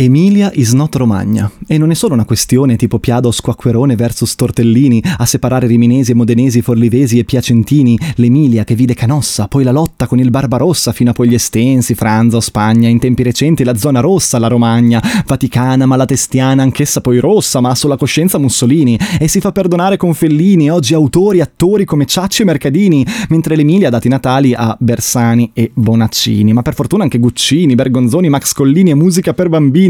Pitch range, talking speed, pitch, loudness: 120-155 Hz, 185 wpm, 130 Hz, -10 LUFS